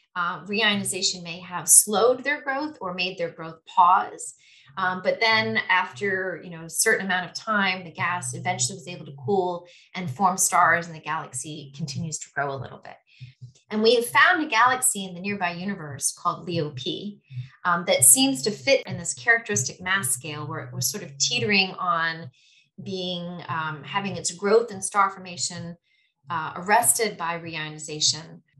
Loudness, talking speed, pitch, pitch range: -23 LUFS, 175 wpm, 175 Hz, 160-200 Hz